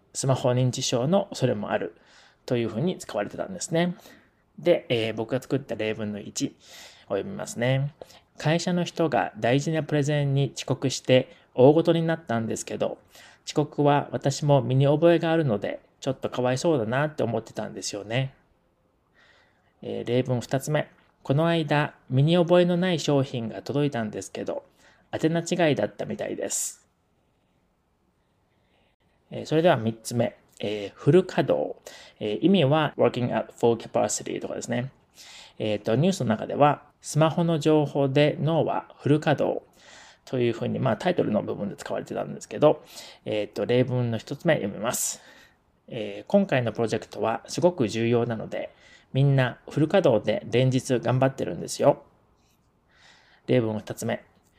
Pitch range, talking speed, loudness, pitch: 115-160 Hz, 325 characters per minute, -25 LUFS, 135 Hz